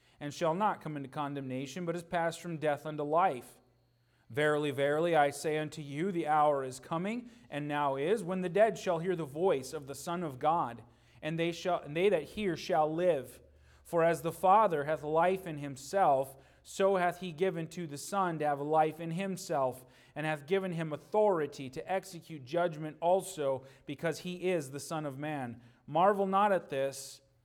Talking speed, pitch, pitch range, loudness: 190 wpm, 155 Hz, 140-175 Hz, -33 LUFS